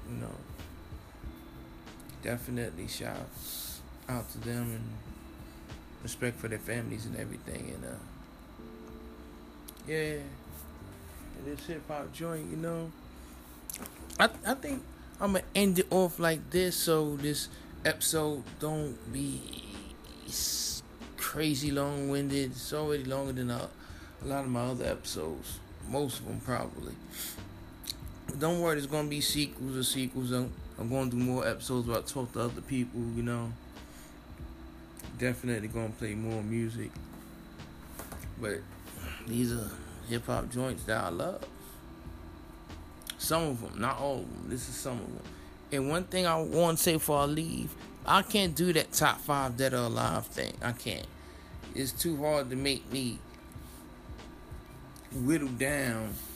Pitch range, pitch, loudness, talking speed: 85-145 Hz, 120 Hz, -33 LUFS, 145 wpm